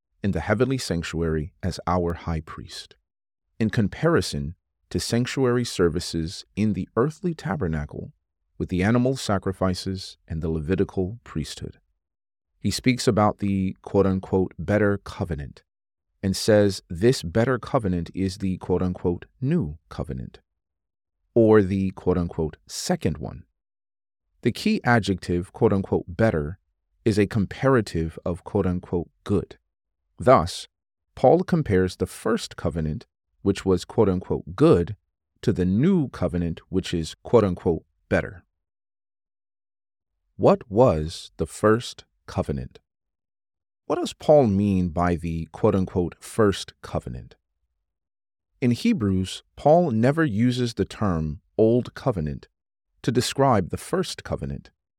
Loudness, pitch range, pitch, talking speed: -24 LUFS, 80-105 Hz, 95 Hz, 120 wpm